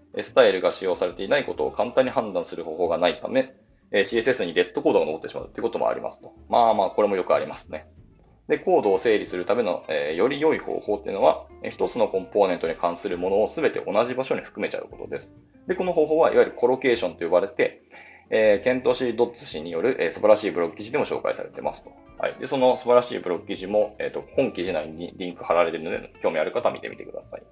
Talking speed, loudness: 510 characters per minute, -24 LUFS